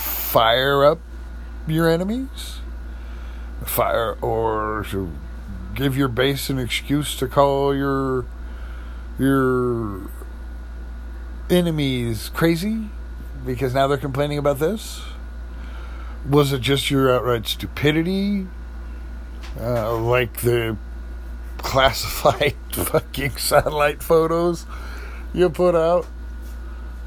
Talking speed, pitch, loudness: 90 wpm, 115 Hz, -21 LUFS